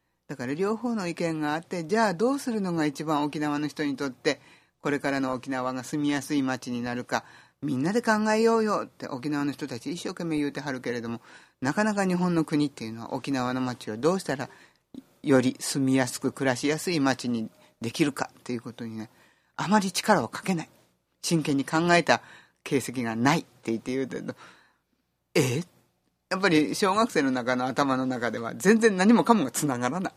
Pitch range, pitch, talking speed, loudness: 125-170 Hz, 145 Hz, 375 characters per minute, -27 LUFS